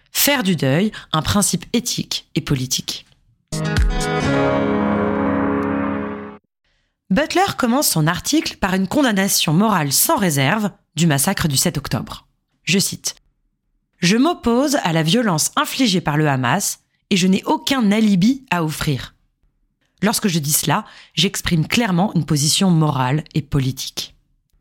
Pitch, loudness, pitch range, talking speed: 175 Hz, -18 LUFS, 140-210 Hz, 125 wpm